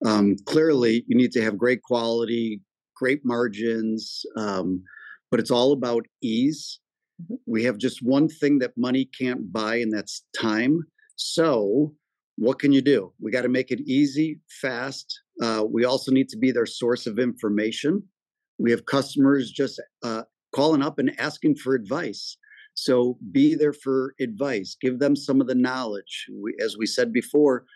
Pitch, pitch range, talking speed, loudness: 130 Hz, 115-145 Hz, 165 wpm, -24 LUFS